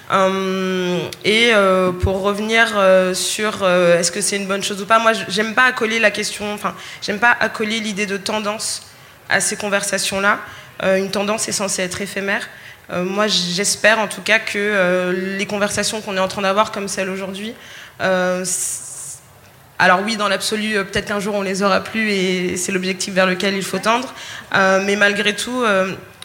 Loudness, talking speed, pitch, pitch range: -17 LUFS, 190 wpm, 200 Hz, 190-210 Hz